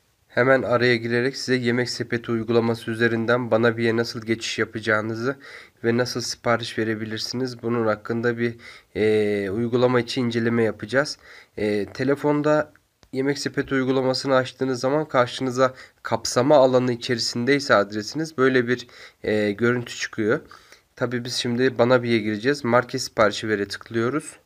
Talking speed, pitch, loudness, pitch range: 130 wpm, 120 Hz, -22 LUFS, 115-130 Hz